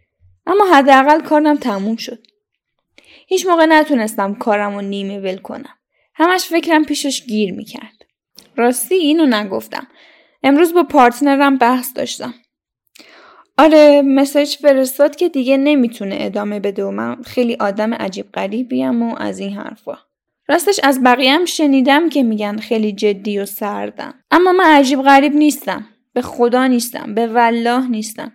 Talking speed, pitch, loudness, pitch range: 140 wpm, 255 Hz, -14 LUFS, 220-295 Hz